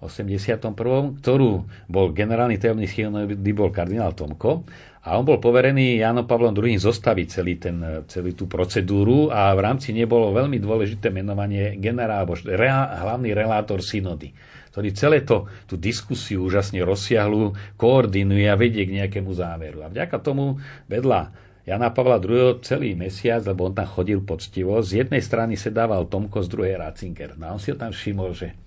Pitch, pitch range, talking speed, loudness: 105 Hz, 95-115 Hz, 160 wpm, -22 LUFS